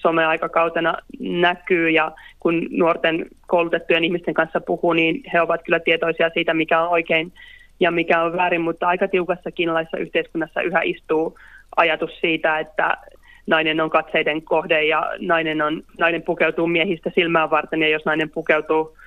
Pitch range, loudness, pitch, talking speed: 160-170 Hz, -20 LUFS, 165 Hz, 150 wpm